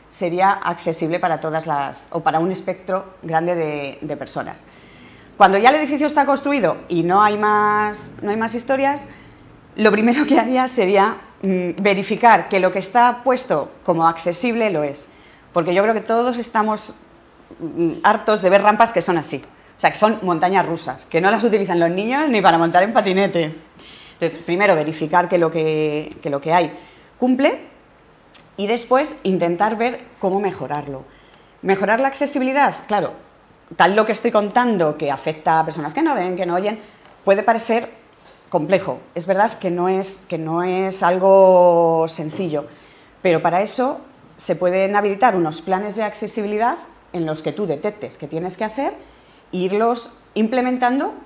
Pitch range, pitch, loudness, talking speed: 170-225 Hz, 195 Hz, -18 LUFS, 165 wpm